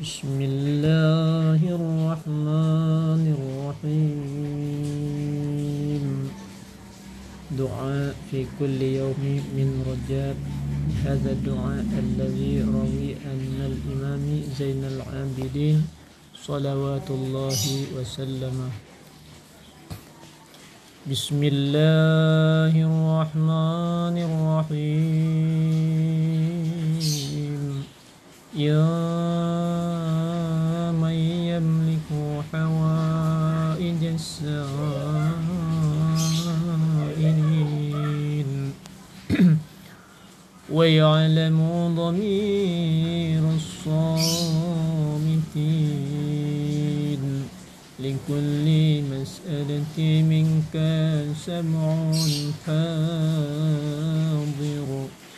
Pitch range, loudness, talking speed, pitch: 140-160 Hz, -24 LUFS, 40 wpm, 155 Hz